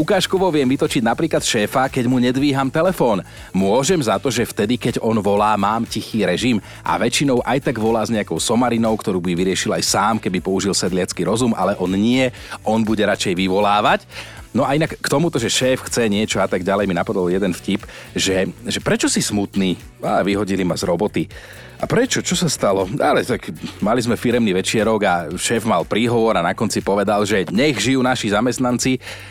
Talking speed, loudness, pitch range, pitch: 190 wpm, -18 LUFS, 100-130 Hz, 110 Hz